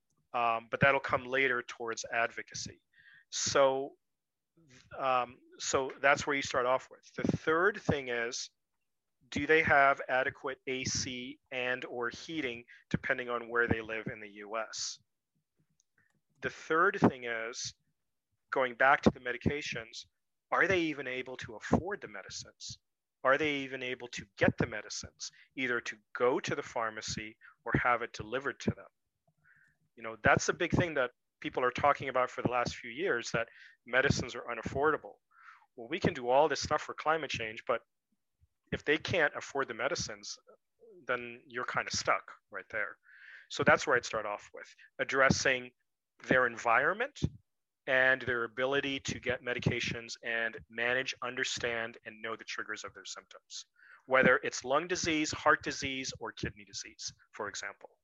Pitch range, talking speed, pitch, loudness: 120-140 Hz, 160 wpm, 130 Hz, -32 LUFS